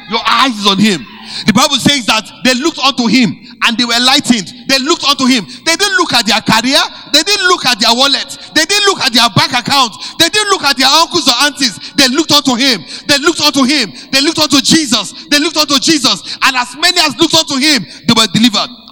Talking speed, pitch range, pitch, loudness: 230 wpm, 240-310 Hz, 270 Hz, -9 LUFS